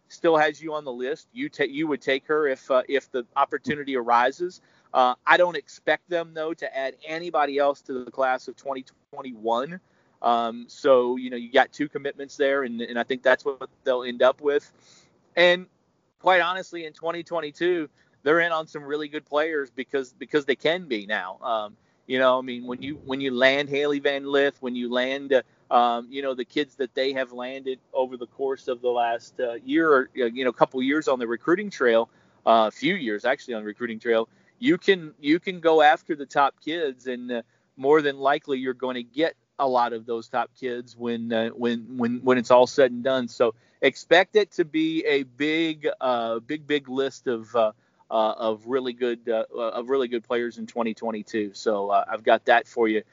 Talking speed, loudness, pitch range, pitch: 210 wpm, -24 LUFS, 120-155 Hz, 135 Hz